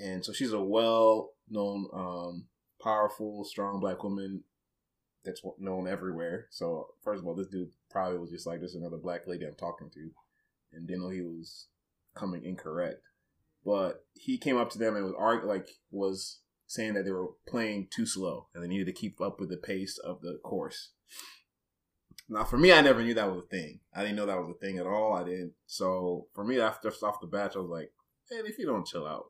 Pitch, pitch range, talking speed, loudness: 95 Hz, 90-105 Hz, 215 wpm, -32 LUFS